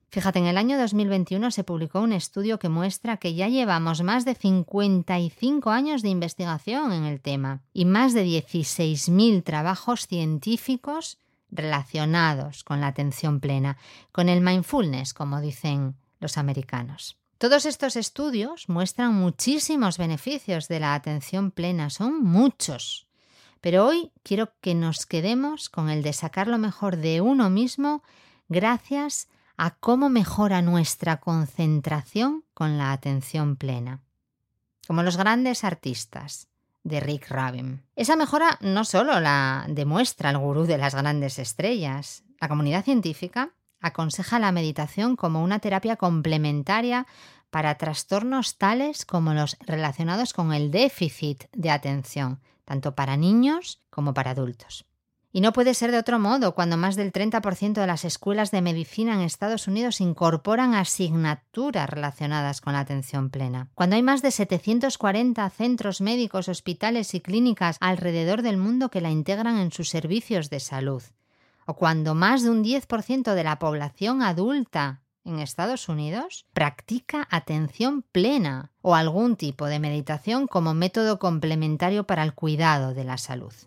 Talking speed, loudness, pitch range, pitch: 145 wpm, -25 LUFS, 150-220 Hz, 180 Hz